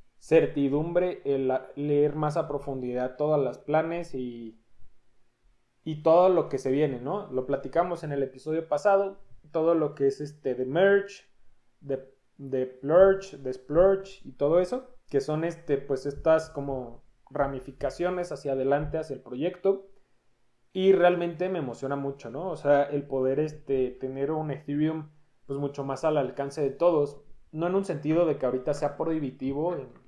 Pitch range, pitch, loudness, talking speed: 135-170 Hz, 145 Hz, -27 LUFS, 160 wpm